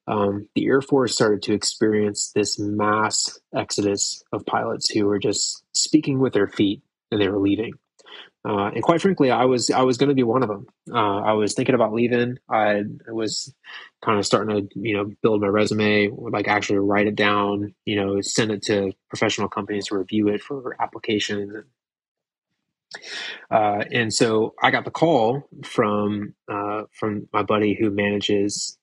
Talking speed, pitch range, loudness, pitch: 175 wpm, 100-115 Hz, -22 LUFS, 105 Hz